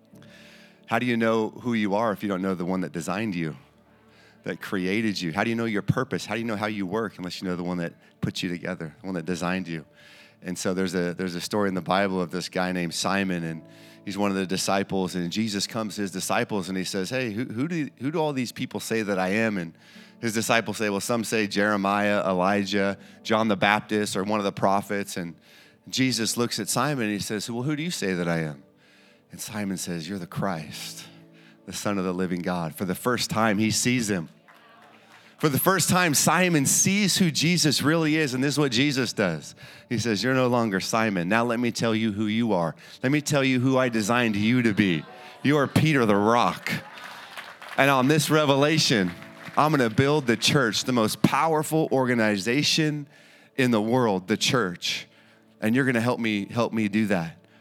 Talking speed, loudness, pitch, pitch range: 225 wpm, -25 LUFS, 110 Hz, 95-125 Hz